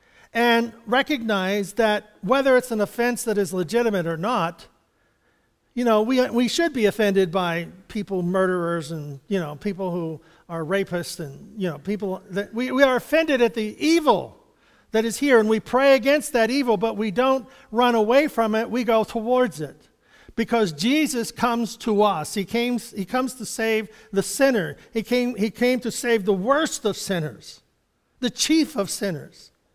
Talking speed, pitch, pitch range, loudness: 180 wpm, 220 Hz, 195-245 Hz, -22 LUFS